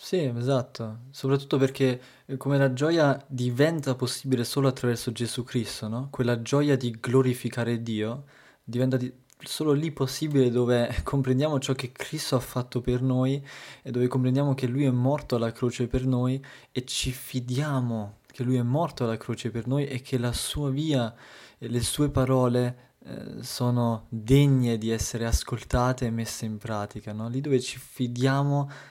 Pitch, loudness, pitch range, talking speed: 130 Hz, -27 LUFS, 120-135 Hz, 165 wpm